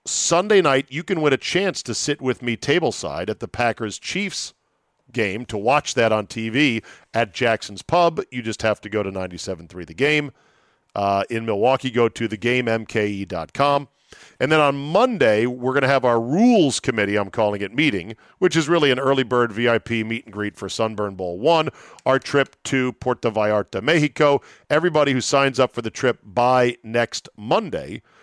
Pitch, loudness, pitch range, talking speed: 120 Hz, -21 LUFS, 110-140 Hz, 180 wpm